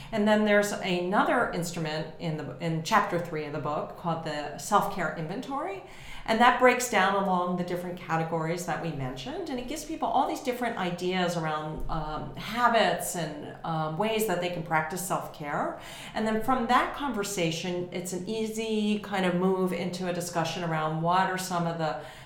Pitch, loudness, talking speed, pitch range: 180 Hz, -28 LUFS, 180 wpm, 160-215 Hz